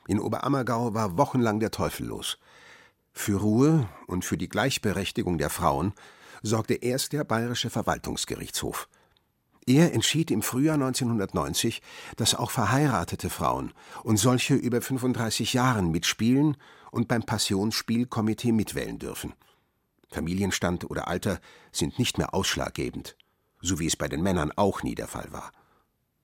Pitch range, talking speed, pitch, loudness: 95-125 Hz, 135 wpm, 115 Hz, -27 LUFS